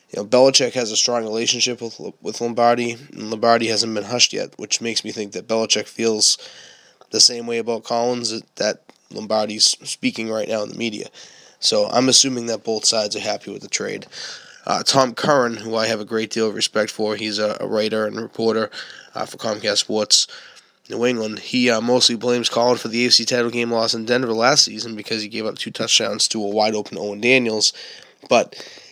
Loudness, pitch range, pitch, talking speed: -19 LUFS, 110-120 Hz, 115 Hz, 200 wpm